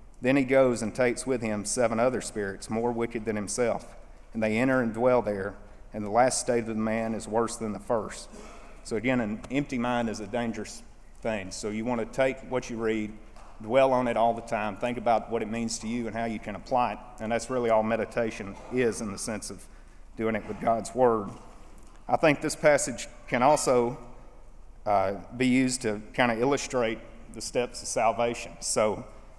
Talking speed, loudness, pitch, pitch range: 205 wpm, -28 LUFS, 115 Hz, 110-125 Hz